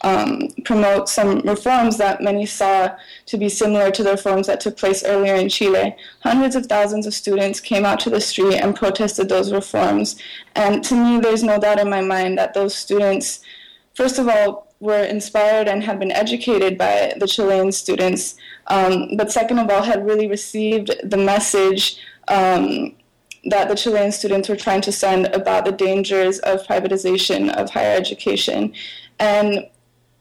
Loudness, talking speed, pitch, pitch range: -18 LUFS, 170 wpm, 205 Hz, 195-215 Hz